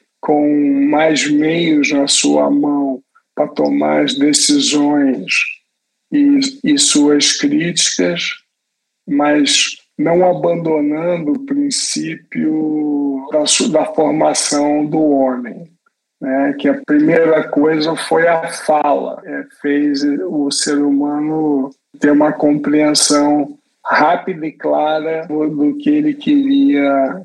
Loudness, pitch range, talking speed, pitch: -14 LUFS, 145-170 Hz, 105 wpm, 150 Hz